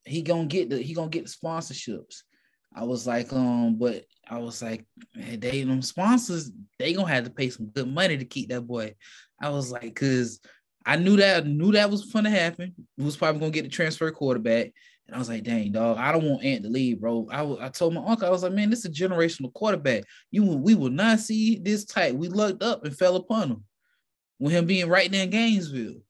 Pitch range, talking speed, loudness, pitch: 125-190 Hz, 230 wpm, -25 LUFS, 155 Hz